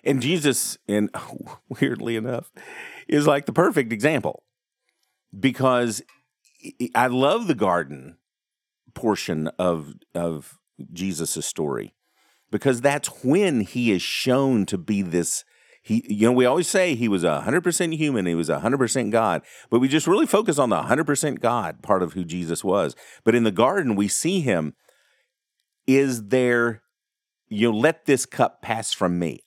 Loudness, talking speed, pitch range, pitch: -22 LUFS, 150 wpm, 90-135 Hz, 115 Hz